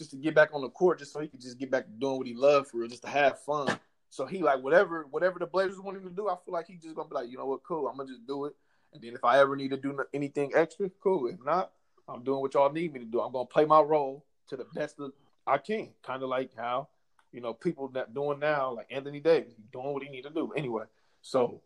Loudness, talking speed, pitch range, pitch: -30 LUFS, 290 wpm, 130-160 Hz, 140 Hz